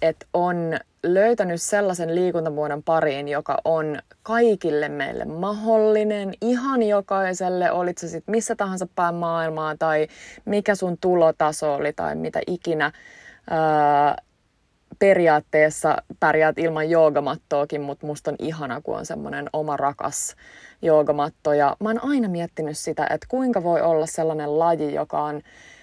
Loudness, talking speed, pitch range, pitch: -22 LUFS, 130 wpm, 150-190 Hz, 165 Hz